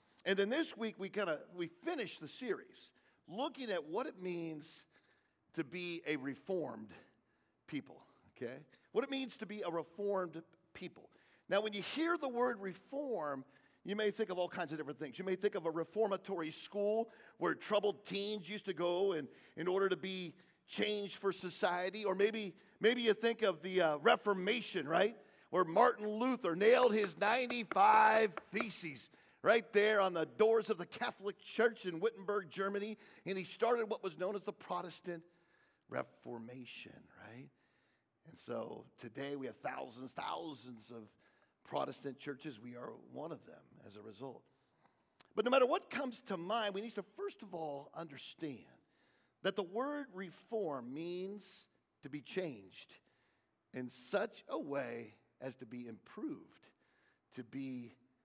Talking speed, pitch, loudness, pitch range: 160 wpm, 190 Hz, -38 LUFS, 160-215 Hz